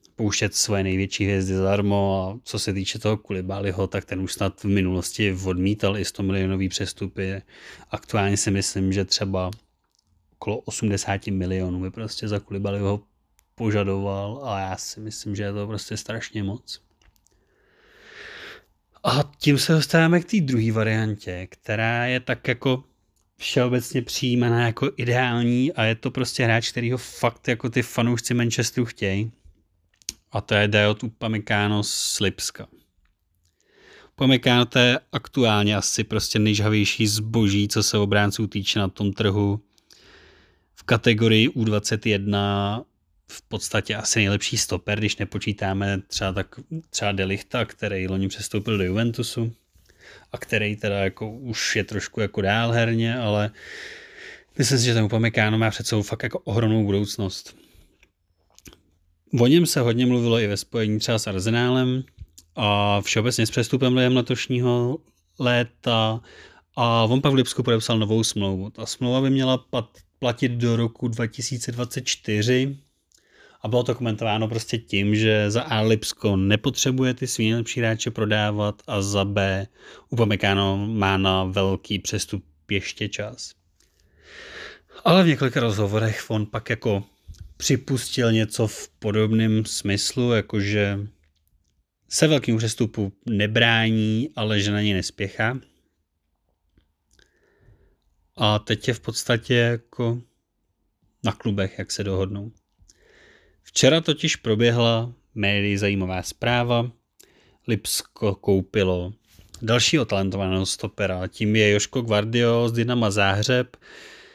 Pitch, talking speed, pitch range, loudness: 110 Hz, 130 wpm, 100-120 Hz, -23 LUFS